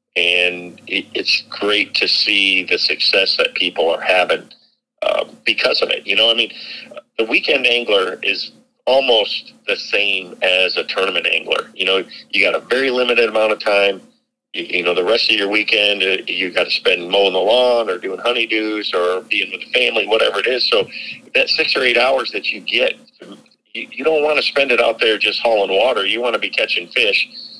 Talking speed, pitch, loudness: 200 wpm, 245 Hz, -15 LUFS